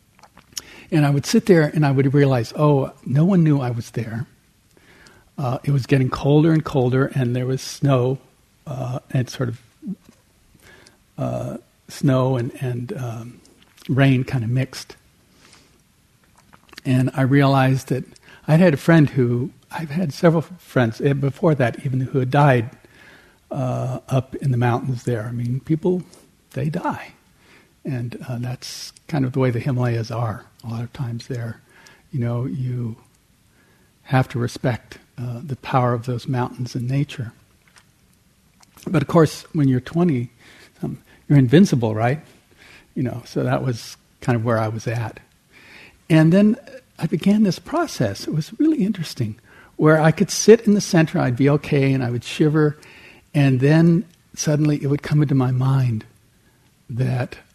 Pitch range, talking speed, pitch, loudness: 125-155 Hz, 160 wpm, 135 Hz, -20 LUFS